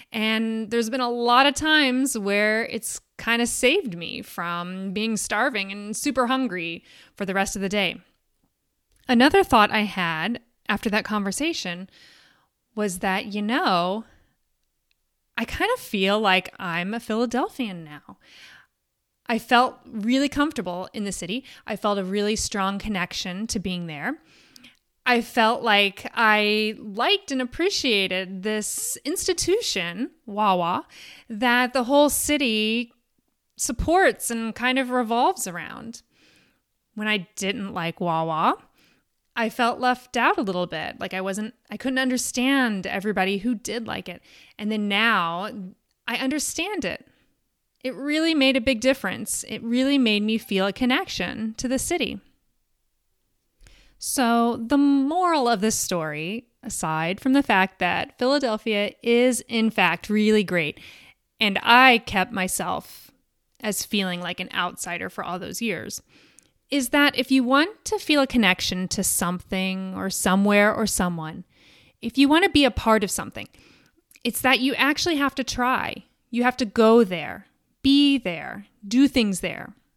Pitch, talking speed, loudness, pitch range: 225 Hz, 150 wpm, -23 LUFS, 195-255 Hz